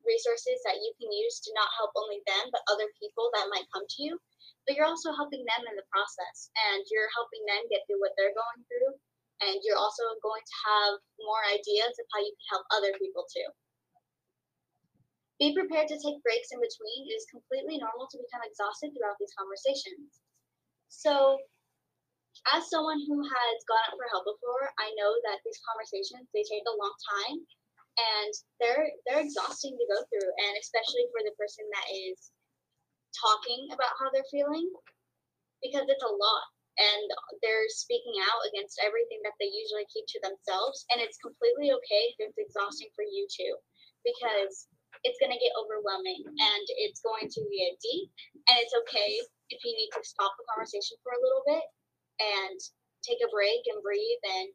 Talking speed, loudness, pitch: 185 wpm, -31 LUFS, 245 Hz